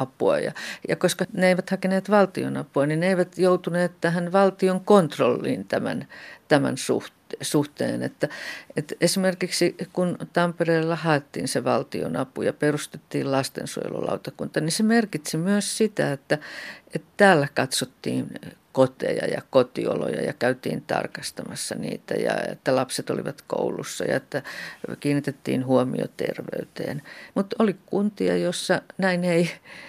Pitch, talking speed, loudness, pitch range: 175 Hz, 120 wpm, -24 LUFS, 150-190 Hz